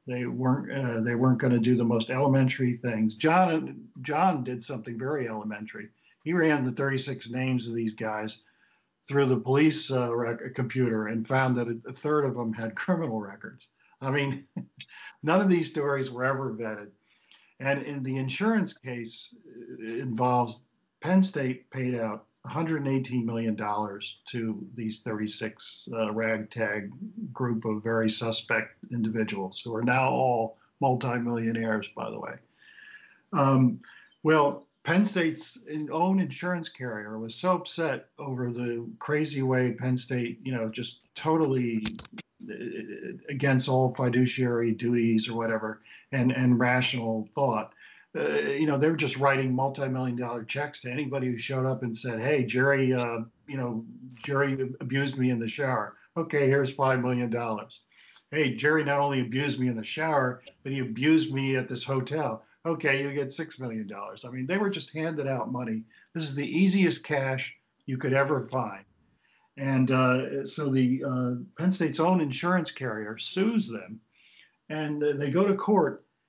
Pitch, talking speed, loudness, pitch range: 130 Hz, 160 wpm, -28 LUFS, 115-145 Hz